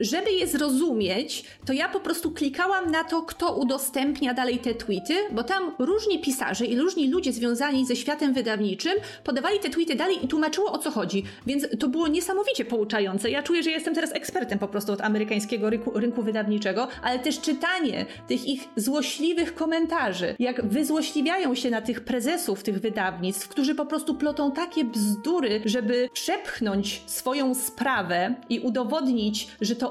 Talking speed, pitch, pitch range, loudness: 165 wpm, 270 Hz, 230-320 Hz, -26 LUFS